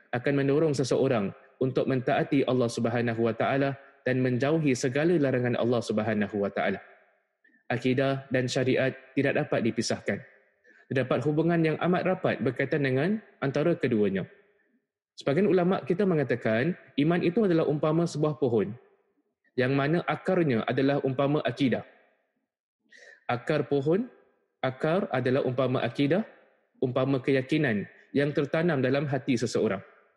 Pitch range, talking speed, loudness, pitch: 130-155 Hz, 120 wpm, -27 LUFS, 140 Hz